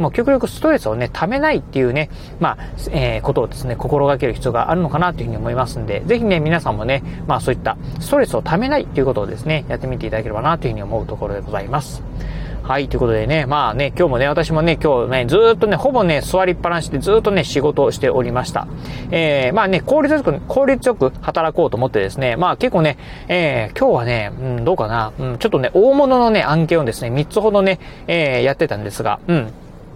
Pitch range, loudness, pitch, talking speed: 125-180 Hz, -17 LUFS, 150 Hz, 485 characters per minute